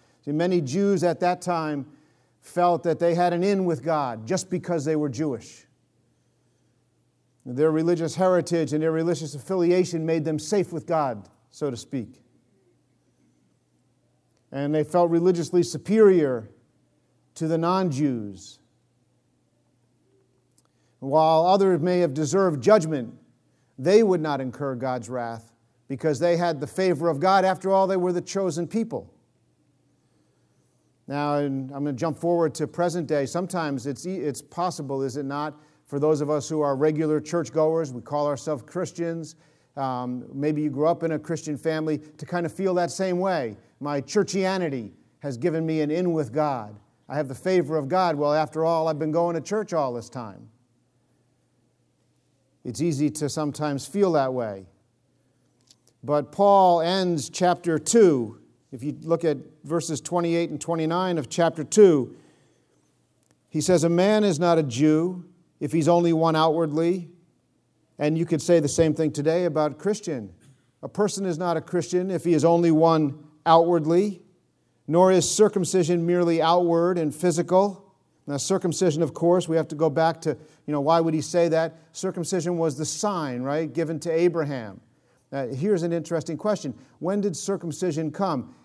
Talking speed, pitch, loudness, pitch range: 160 wpm, 160 Hz, -24 LUFS, 145-175 Hz